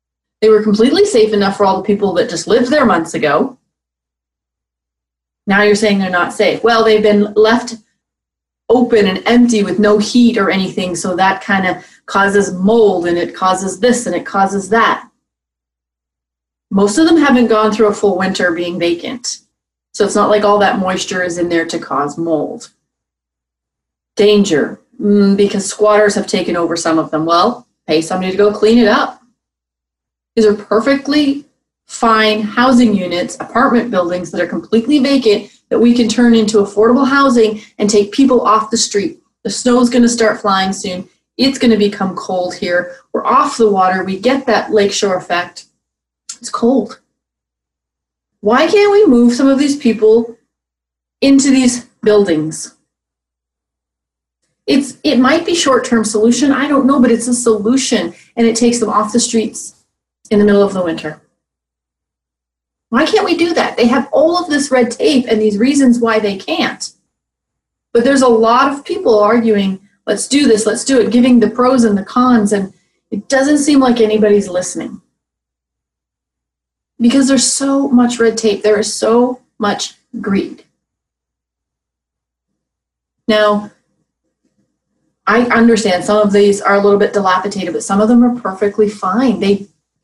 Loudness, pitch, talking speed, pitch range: -12 LUFS, 210 Hz, 165 wpm, 180-240 Hz